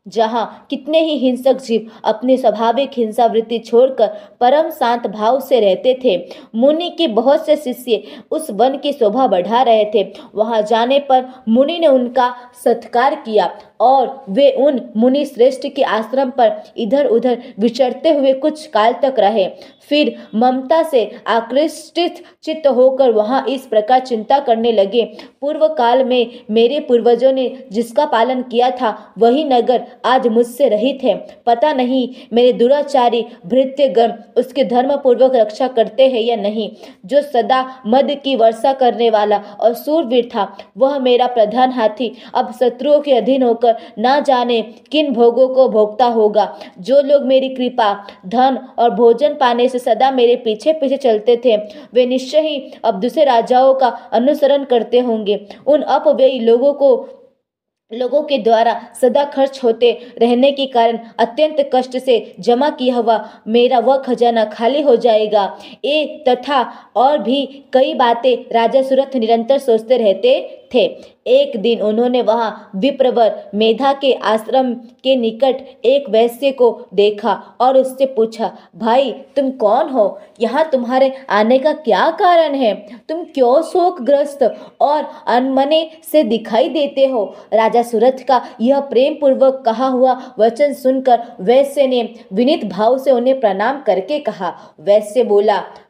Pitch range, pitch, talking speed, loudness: 230-275 Hz, 250 Hz, 150 wpm, -15 LUFS